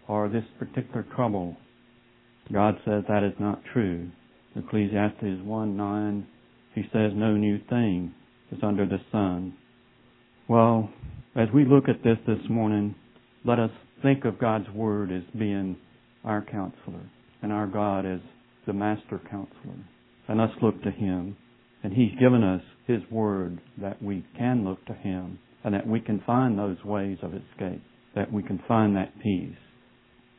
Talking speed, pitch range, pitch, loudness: 155 wpm, 100-120 Hz, 105 Hz, -27 LUFS